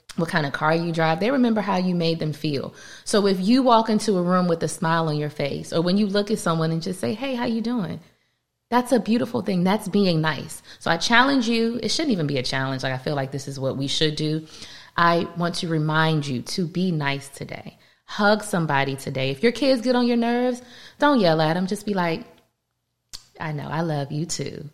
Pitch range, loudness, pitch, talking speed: 155-220 Hz, -22 LUFS, 170 Hz, 240 wpm